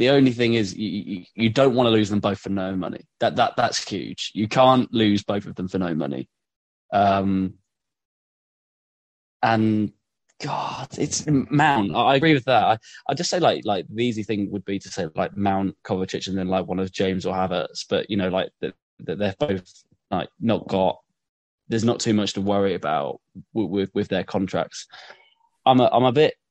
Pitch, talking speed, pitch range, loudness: 100 Hz, 205 wpm, 95-115 Hz, -22 LUFS